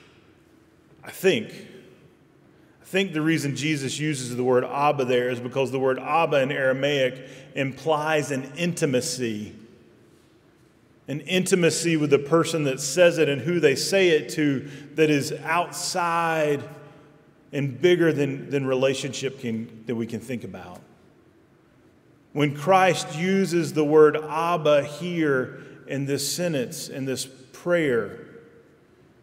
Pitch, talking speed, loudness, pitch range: 145 Hz, 130 wpm, -23 LUFS, 135-165 Hz